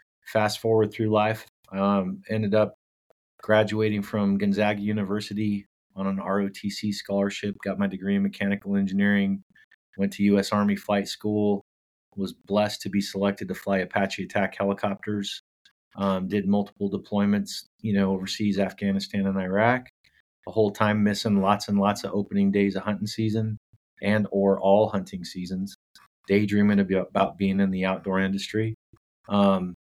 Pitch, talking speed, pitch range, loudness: 100 Hz, 145 wpm, 100-105 Hz, -25 LUFS